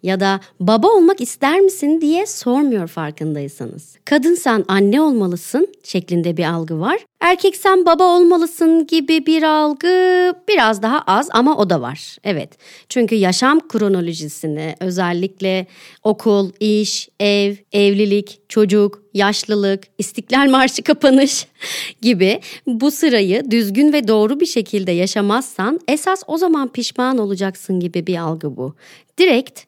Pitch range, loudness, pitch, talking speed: 190-305 Hz, -16 LUFS, 220 Hz, 130 wpm